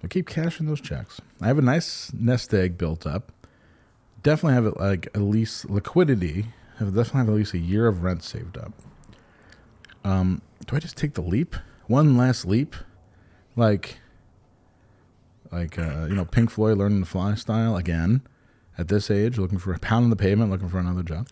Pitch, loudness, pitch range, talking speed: 105 Hz, -24 LUFS, 95-120 Hz, 190 wpm